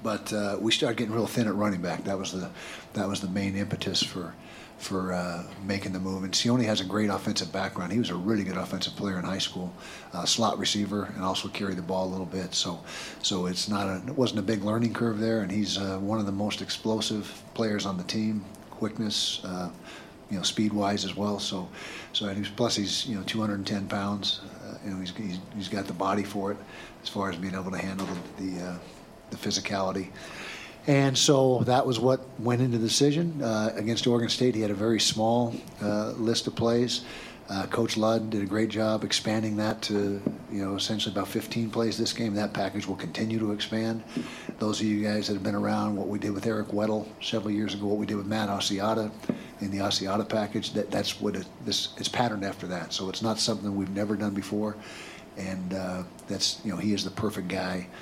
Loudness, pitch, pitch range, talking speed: -29 LUFS, 105 Hz, 95-110 Hz, 220 wpm